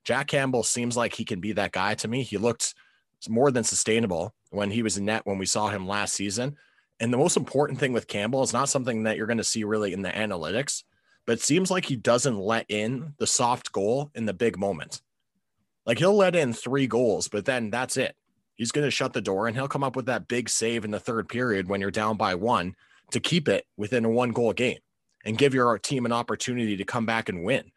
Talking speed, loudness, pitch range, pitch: 245 wpm, -26 LUFS, 105-130 Hz, 115 Hz